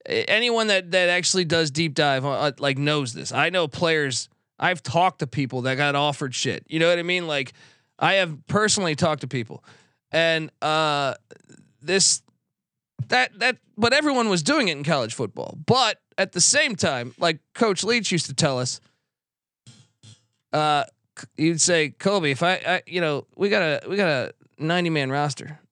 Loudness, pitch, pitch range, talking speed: -22 LUFS, 155 Hz, 140-180 Hz, 180 wpm